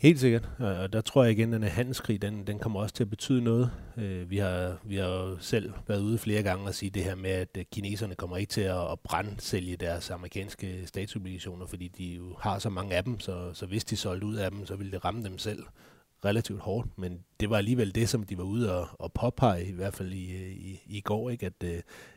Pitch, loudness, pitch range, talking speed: 100 Hz, -32 LUFS, 90-110 Hz, 240 wpm